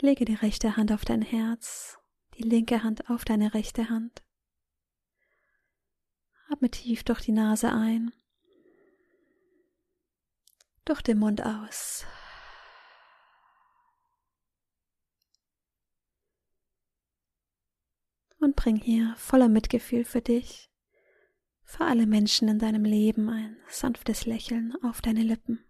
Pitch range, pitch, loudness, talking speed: 225-350 Hz, 235 Hz, -27 LUFS, 100 wpm